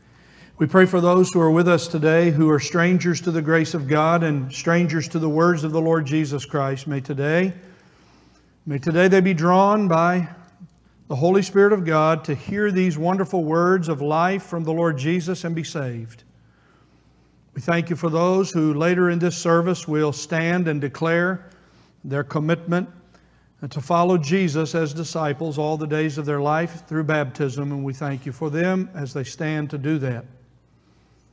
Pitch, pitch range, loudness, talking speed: 160 Hz, 145-175 Hz, -21 LUFS, 180 wpm